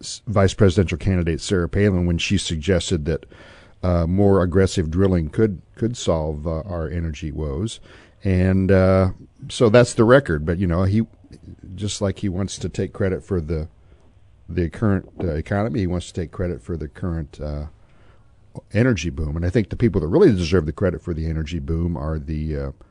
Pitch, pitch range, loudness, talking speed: 90 Hz, 80-100 Hz, -21 LUFS, 185 wpm